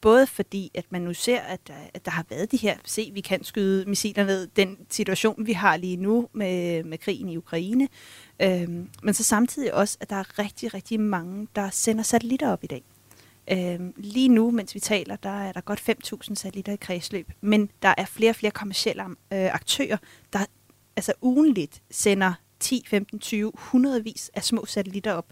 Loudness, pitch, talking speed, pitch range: -25 LUFS, 200 Hz, 200 wpm, 185-220 Hz